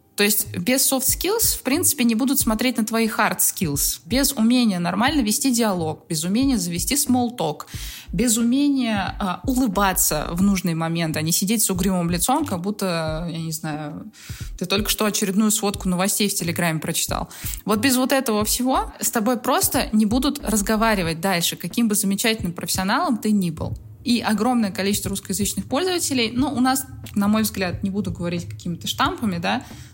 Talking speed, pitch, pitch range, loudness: 175 wpm, 210 Hz, 185-245 Hz, -21 LUFS